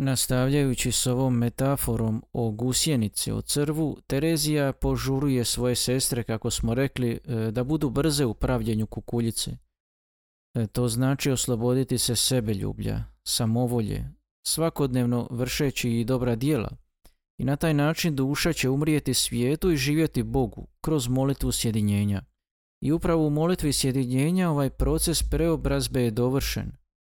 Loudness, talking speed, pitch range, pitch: -25 LUFS, 125 wpm, 120-145 Hz, 130 Hz